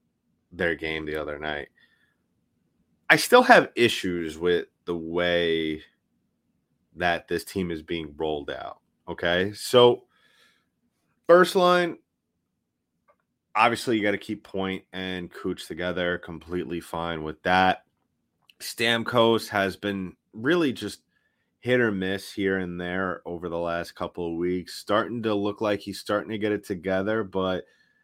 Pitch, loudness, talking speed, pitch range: 95 Hz, -25 LUFS, 135 wpm, 85-105 Hz